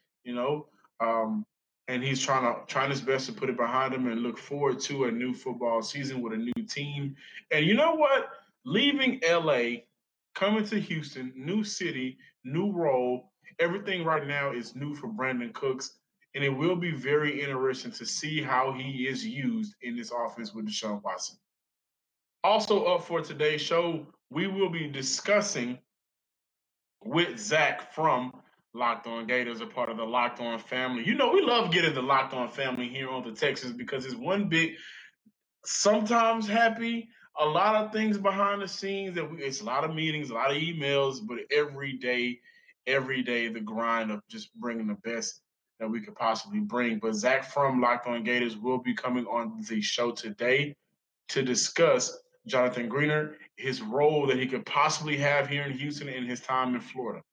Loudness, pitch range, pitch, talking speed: -29 LUFS, 125-170 Hz, 135 Hz, 180 wpm